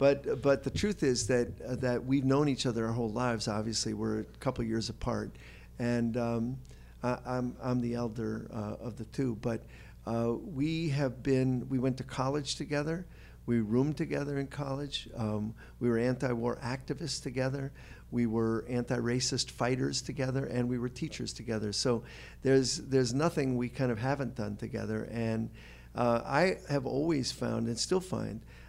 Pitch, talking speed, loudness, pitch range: 125 Hz, 175 wpm, -33 LUFS, 115-135 Hz